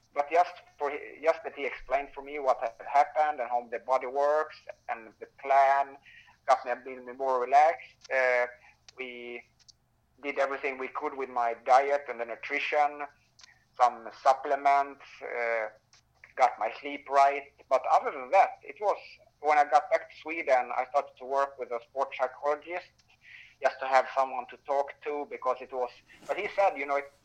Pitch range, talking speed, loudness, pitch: 125-145 Hz, 180 wpm, -29 LUFS, 140 Hz